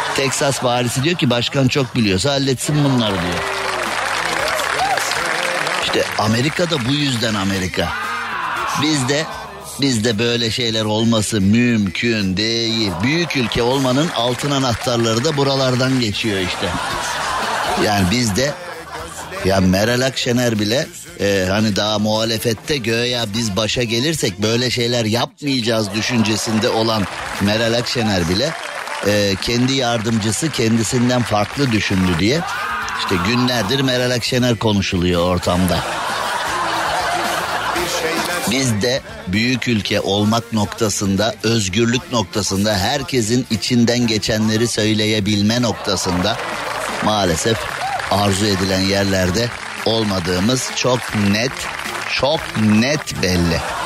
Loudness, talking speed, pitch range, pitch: -17 LUFS, 105 wpm, 105-125 Hz, 115 Hz